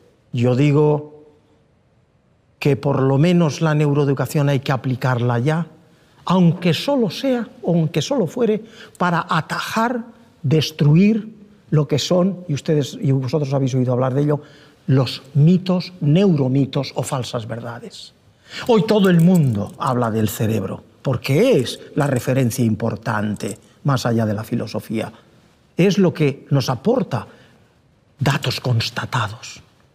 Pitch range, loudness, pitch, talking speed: 130-170 Hz, -19 LUFS, 145 Hz, 130 wpm